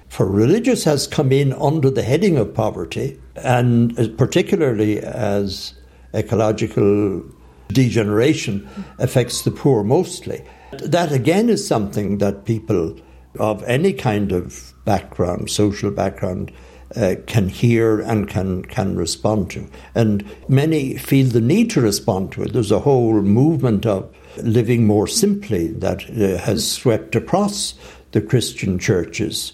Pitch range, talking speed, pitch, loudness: 100-130 Hz, 130 wpm, 110 Hz, -18 LUFS